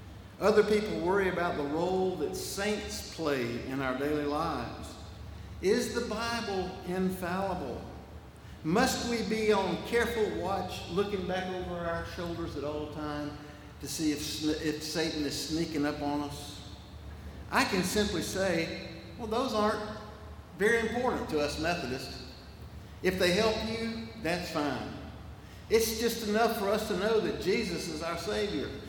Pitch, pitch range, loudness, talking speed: 175 Hz, 145-210 Hz, -31 LUFS, 145 wpm